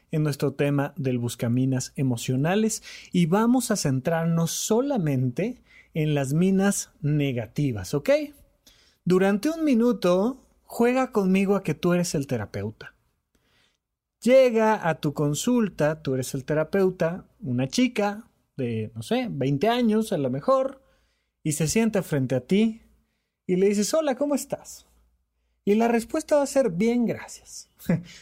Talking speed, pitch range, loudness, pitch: 140 wpm, 140-225 Hz, -24 LUFS, 175 Hz